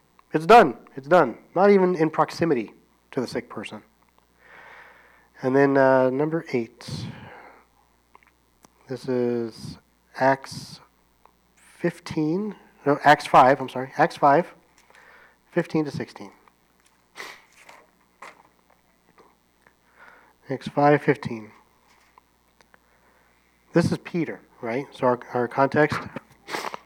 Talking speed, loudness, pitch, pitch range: 95 wpm, -22 LUFS, 140 Hz, 120-160 Hz